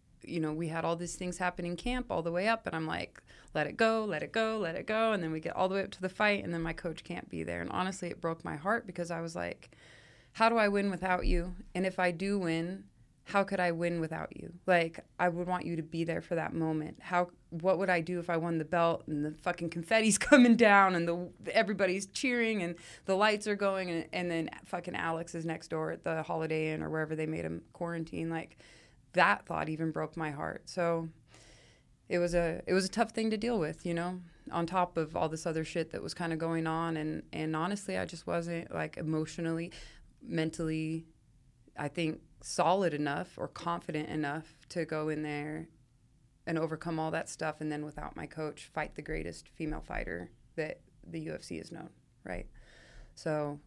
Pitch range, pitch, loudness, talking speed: 155-180 Hz, 170 Hz, -33 LUFS, 225 wpm